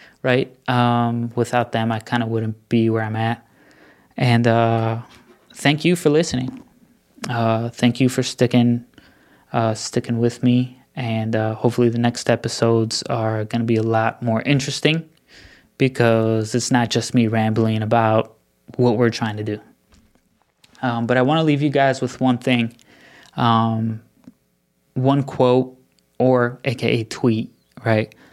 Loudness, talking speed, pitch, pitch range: -20 LUFS, 150 wpm, 120 Hz, 115-130 Hz